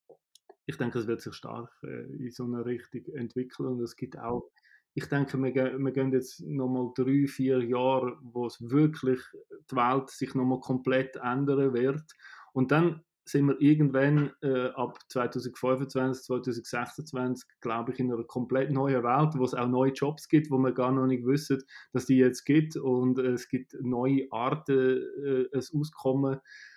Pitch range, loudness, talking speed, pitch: 125-140 Hz, -29 LUFS, 175 wpm, 130 Hz